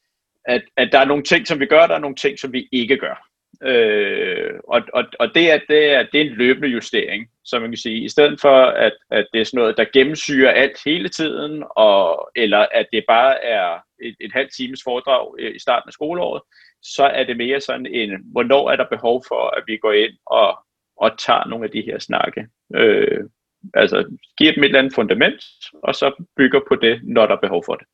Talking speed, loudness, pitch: 225 wpm, -17 LUFS, 140 Hz